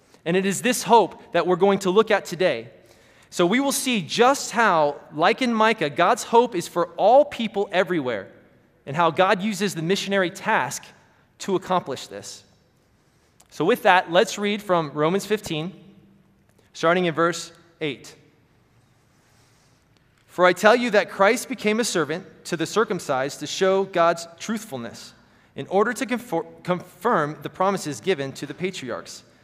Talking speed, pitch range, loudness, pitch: 155 wpm, 150-205 Hz, -22 LUFS, 175 Hz